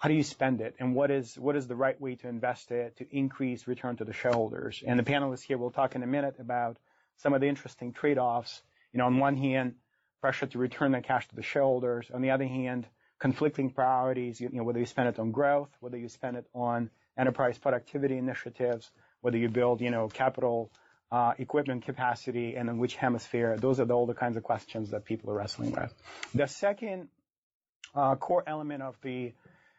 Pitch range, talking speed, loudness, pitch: 120-135 Hz, 210 wpm, -31 LUFS, 125 Hz